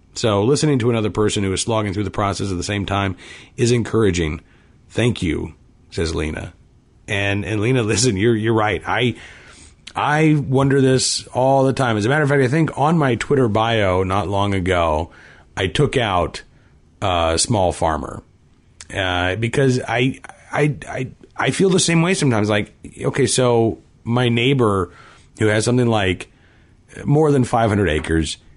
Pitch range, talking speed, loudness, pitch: 95-130 Hz, 170 wpm, -18 LUFS, 110 Hz